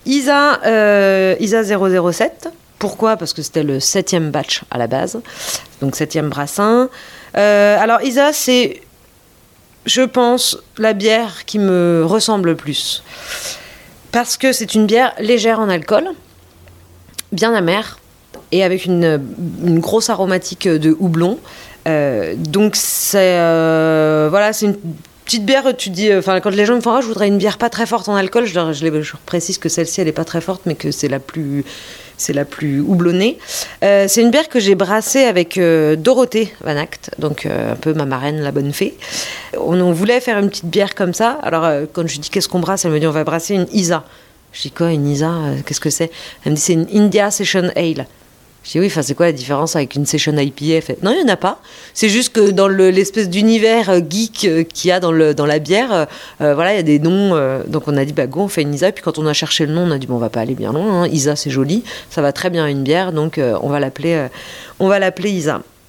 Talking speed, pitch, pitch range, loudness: 225 wpm, 180 Hz, 155-210 Hz, -15 LUFS